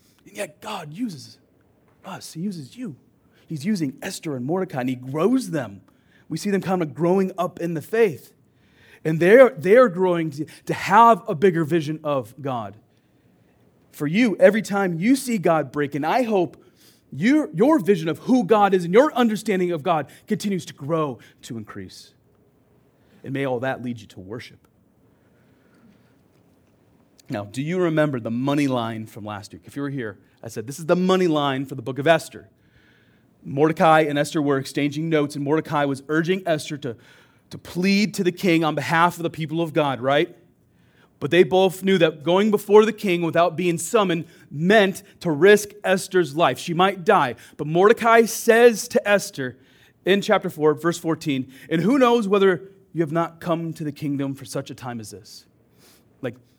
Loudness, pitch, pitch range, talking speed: -21 LUFS, 160 Hz, 135-190 Hz, 180 wpm